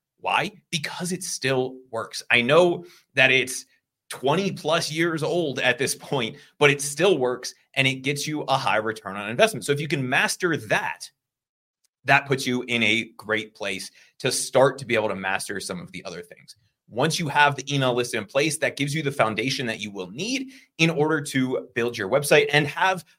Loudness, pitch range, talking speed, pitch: -23 LUFS, 125-160 Hz, 205 wpm, 135 Hz